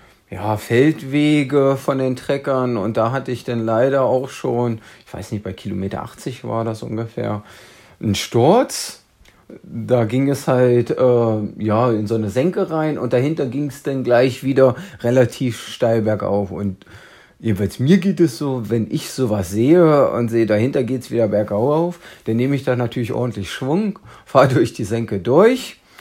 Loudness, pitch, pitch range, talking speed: -18 LUFS, 125 Hz, 110-135 Hz, 170 wpm